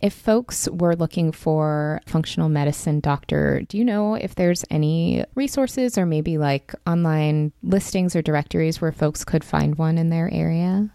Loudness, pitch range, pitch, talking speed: -22 LUFS, 155-190 Hz, 165 Hz, 165 wpm